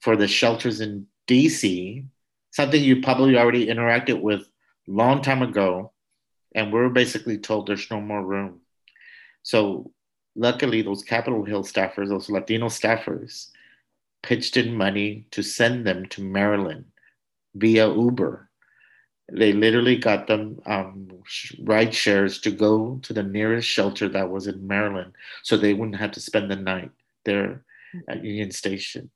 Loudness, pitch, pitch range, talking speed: -22 LUFS, 105 Hz, 100-115 Hz, 145 wpm